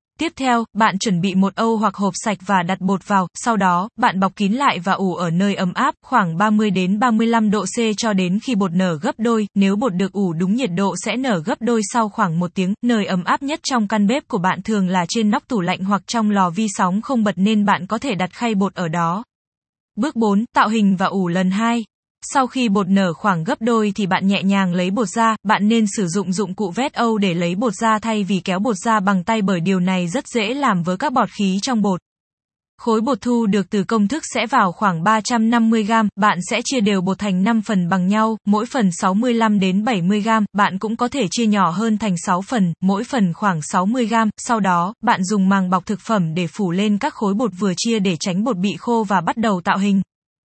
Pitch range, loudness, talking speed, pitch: 190-230 Hz, -18 LUFS, 245 wpm, 210 Hz